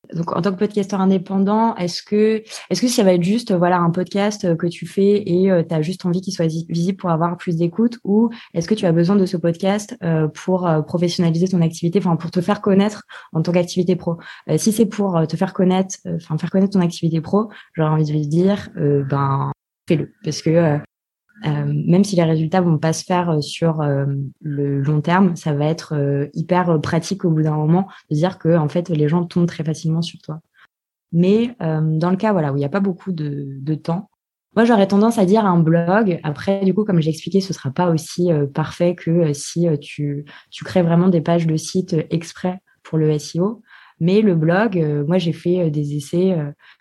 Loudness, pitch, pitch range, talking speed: -19 LUFS, 170 Hz, 160-190 Hz, 230 wpm